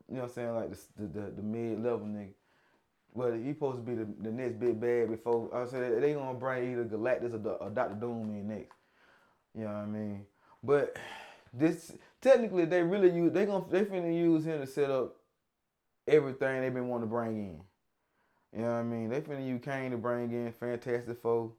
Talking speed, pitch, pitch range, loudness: 215 wpm, 120 Hz, 115-135 Hz, -33 LUFS